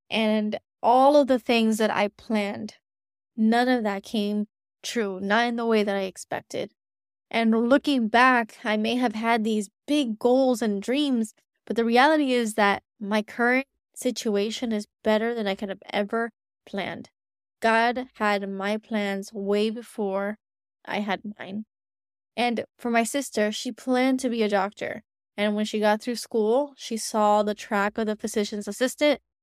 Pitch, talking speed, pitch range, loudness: 220 Hz, 165 wpm, 205-240 Hz, -25 LUFS